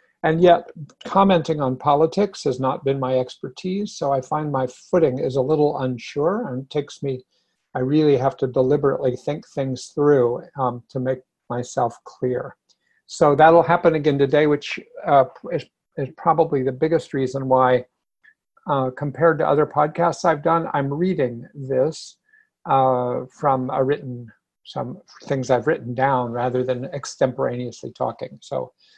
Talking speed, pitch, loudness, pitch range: 150 wpm, 140 Hz, -21 LUFS, 130-160 Hz